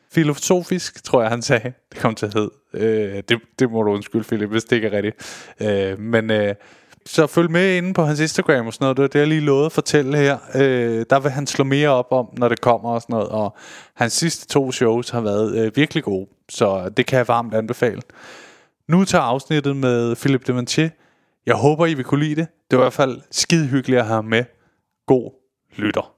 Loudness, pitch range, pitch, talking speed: -19 LUFS, 115-145 Hz, 125 Hz, 225 wpm